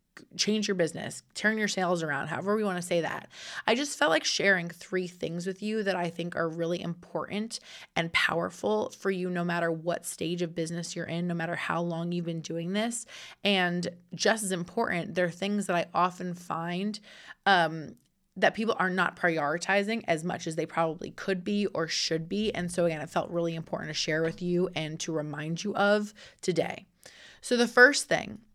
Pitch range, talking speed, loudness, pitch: 165-200 Hz, 200 wpm, -29 LUFS, 175 Hz